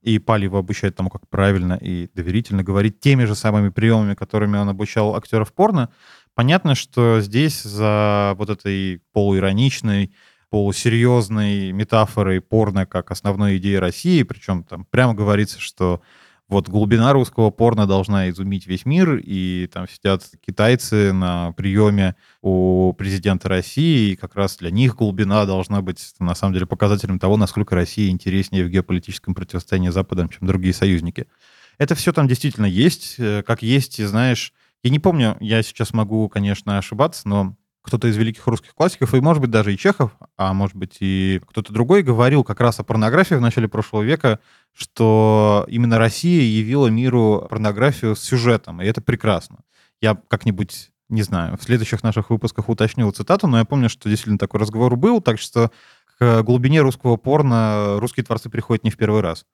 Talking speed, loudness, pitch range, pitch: 165 wpm, -18 LUFS, 95-120 Hz, 105 Hz